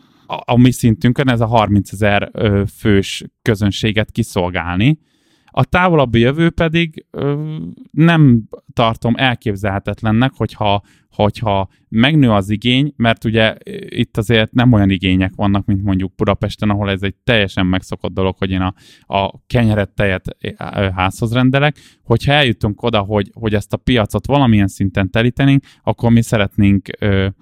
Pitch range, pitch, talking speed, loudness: 100-125 Hz, 110 Hz, 135 wpm, -15 LUFS